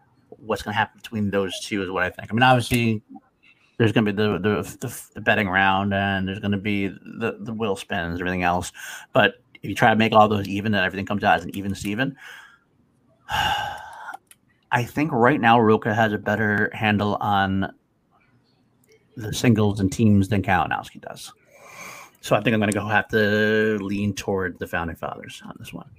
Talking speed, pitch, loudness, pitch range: 200 wpm, 105 Hz, -22 LUFS, 100-110 Hz